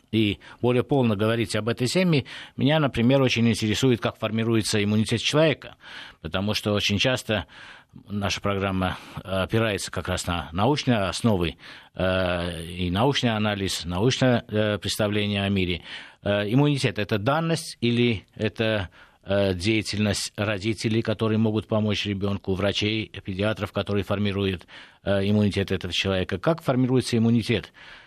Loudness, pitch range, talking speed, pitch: -24 LUFS, 100-120 Hz, 120 wpm, 105 Hz